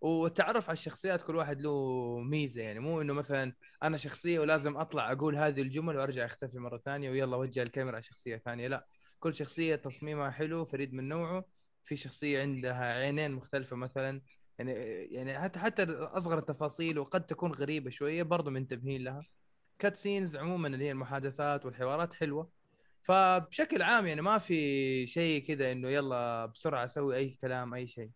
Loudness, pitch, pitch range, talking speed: -34 LUFS, 145 Hz, 130-160 Hz, 165 wpm